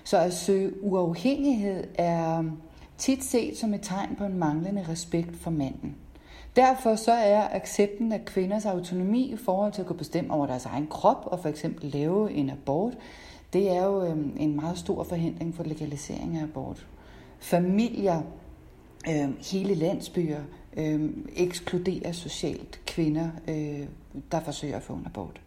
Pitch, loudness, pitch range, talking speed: 170 Hz, -28 LUFS, 150-195 Hz, 145 wpm